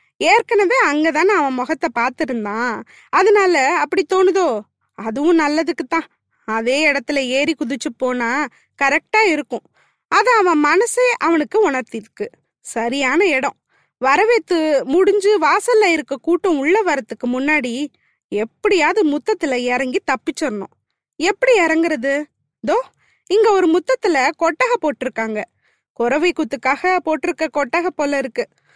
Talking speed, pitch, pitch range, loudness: 105 wpm, 315 Hz, 275-385 Hz, -17 LUFS